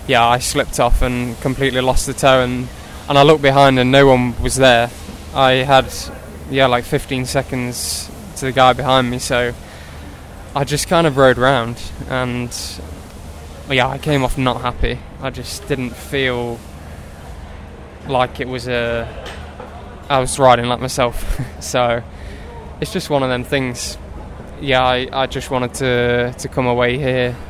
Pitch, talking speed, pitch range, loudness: 125 Hz, 160 wpm, 95-130 Hz, -16 LUFS